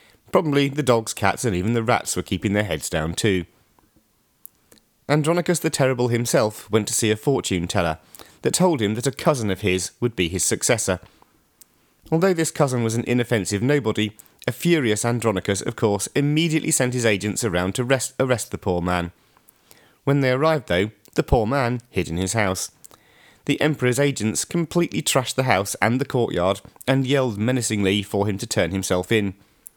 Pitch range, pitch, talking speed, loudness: 100-135 Hz, 115 Hz, 180 wpm, -22 LUFS